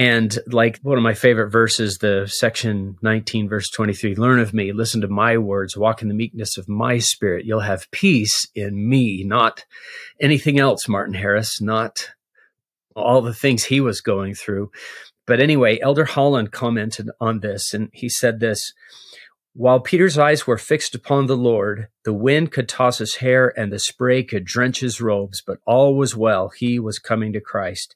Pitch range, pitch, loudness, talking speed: 105-125 Hz, 115 Hz, -19 LUFS, 180 wpm